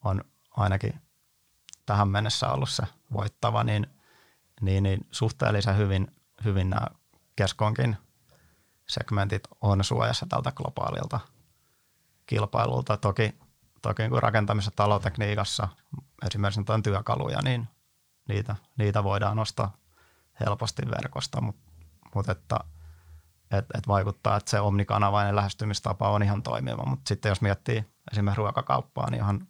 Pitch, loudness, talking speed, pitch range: 105 Hz, -28 LUFS, 115 wpm, 100-115 Hz